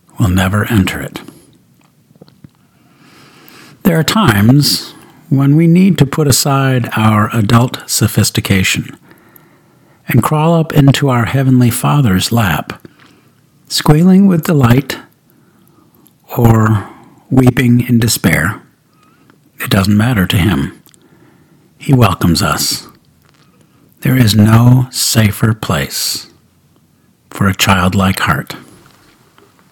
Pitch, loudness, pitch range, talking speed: 125 Hz, -11 LUFS, 110-145 Hz, 95 wpm